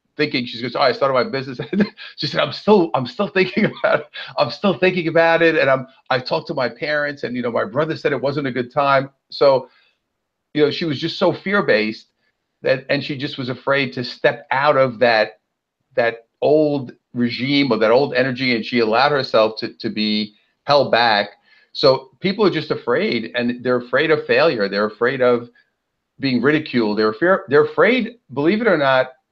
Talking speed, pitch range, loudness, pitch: 205 wpm, 120-160 Hz, -18 LUFS, 135 Hz